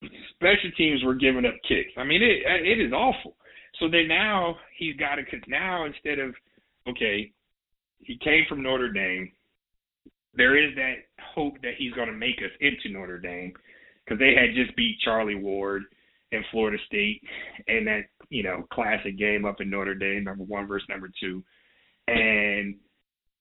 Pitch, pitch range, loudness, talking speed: 115 Hz, 100-150 Hz, -25 LUFS, 170 wpm